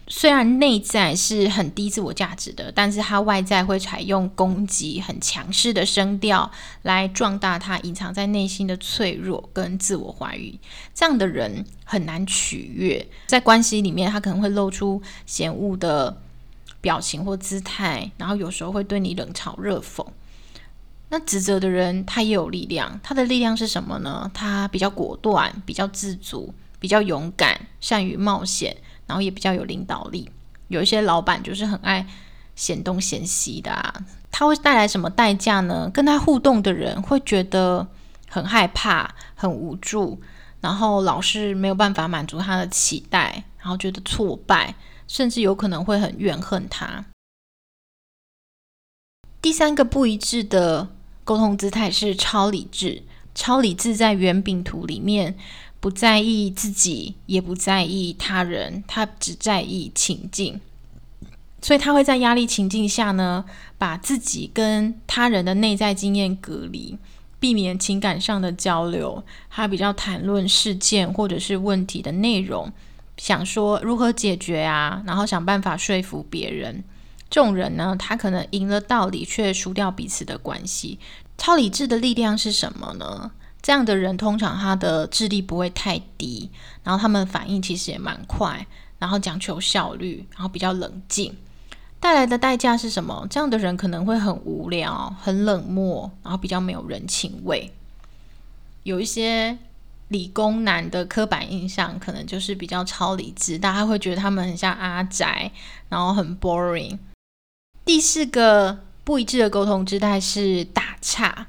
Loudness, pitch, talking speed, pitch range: -21 LUFS, 195 Hz, 245 characters per minute, 185-215 Hz